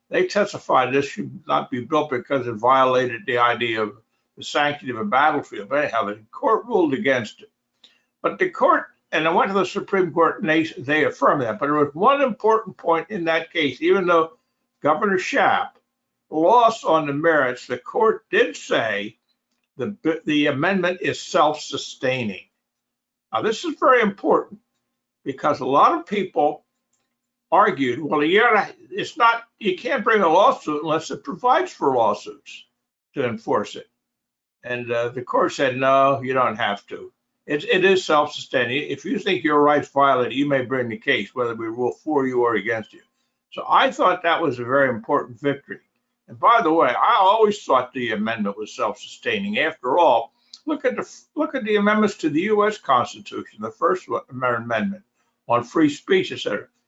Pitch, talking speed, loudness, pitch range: 160 Hz, 175 wpm, -20 LUFS, 130-220 Hz